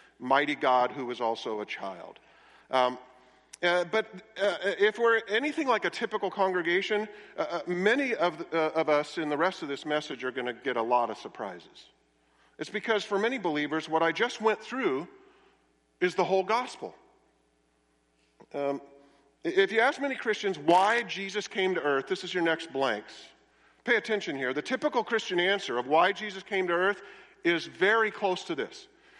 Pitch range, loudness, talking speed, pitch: 140-215 Hz, -28 LUFS, 180 wpm, 185 Hz